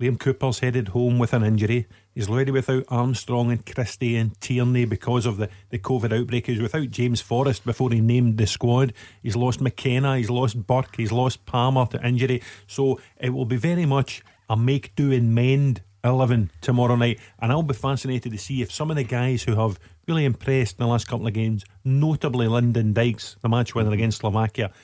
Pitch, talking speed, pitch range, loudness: 120 Hz, 205 wpm, 115-130 Hz, -23 LUFS